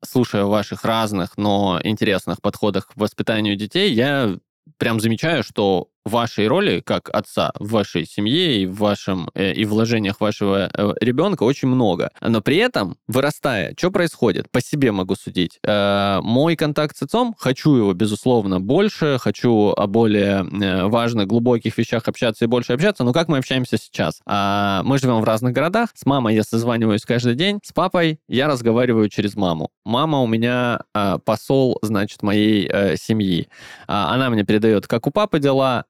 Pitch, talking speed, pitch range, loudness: 115 Hz, 155 wpm, 105-130 Hz, -19 LUFS